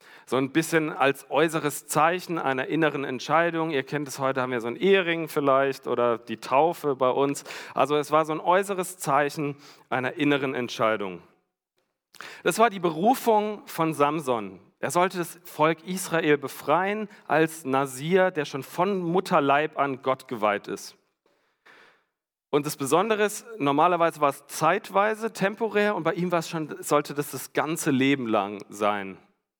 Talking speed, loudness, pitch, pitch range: 160 wpm, -25 LUFS, 150 Hz, 135-175 Hz